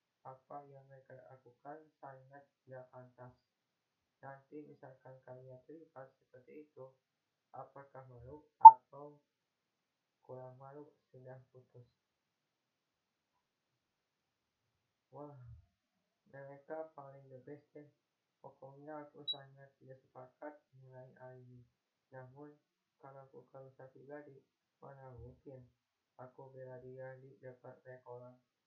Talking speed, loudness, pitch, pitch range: 90 wpm, -23 LUFS, 130 Hz, 130-140 Hz